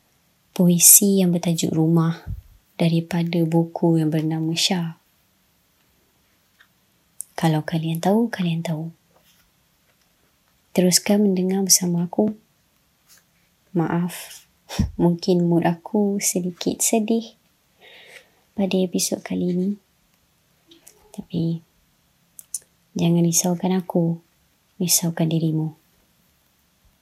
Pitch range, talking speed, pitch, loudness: 165-185 Hz, 75 wpm, 170 Hz, -20 LUFS